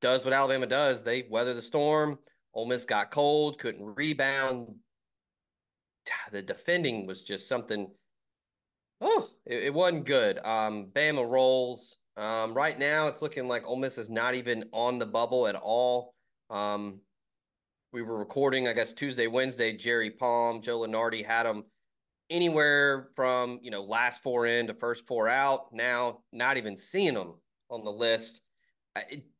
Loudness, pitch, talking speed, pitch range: -29 LUFS, 120 Hz, 155 wpm, 110-135 Hz